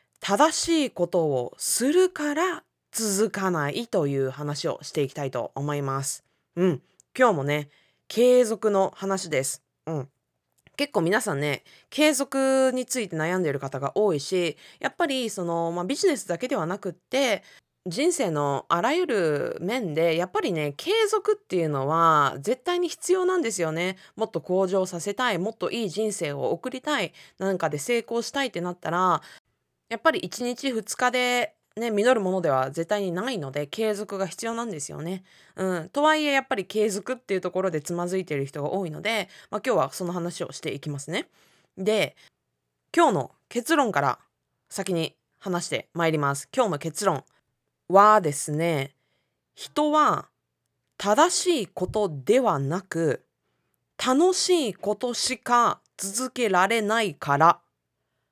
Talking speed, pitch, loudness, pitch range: 310 characters per minute, 195 Hz, -25 LUFS, 165-250 Hz